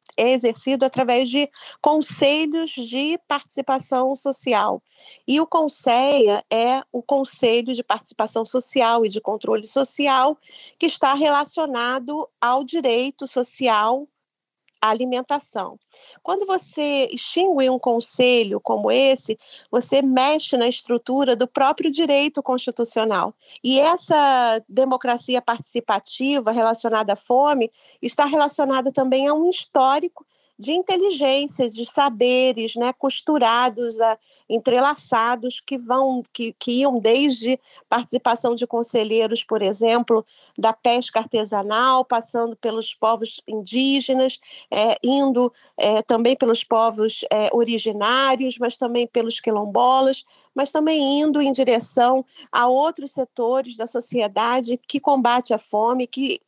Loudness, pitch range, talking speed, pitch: -20 LUFS, 235-275 Hz, 115 wpm, 255 Hz